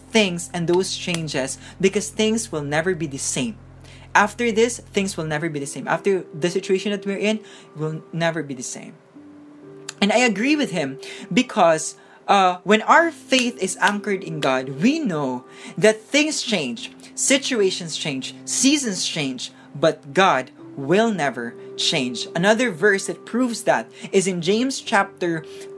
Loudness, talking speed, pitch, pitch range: -21 LUFS, 155 wpm, 190 Hz, 145-220 Hz